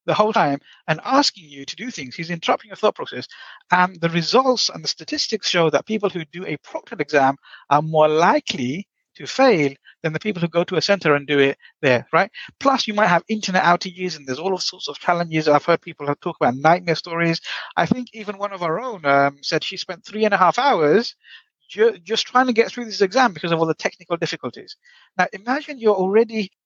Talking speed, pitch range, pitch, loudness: 225 wpm, 160-215 Hz, 180 Hz, -20 LUFS